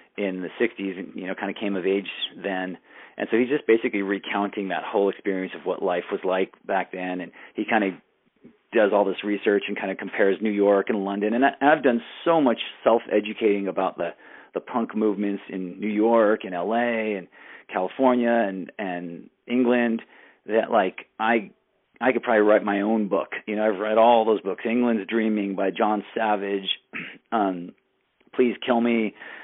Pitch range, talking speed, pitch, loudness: 95-115 Hz, 190 wpm, 105 Hz, -24 LUFS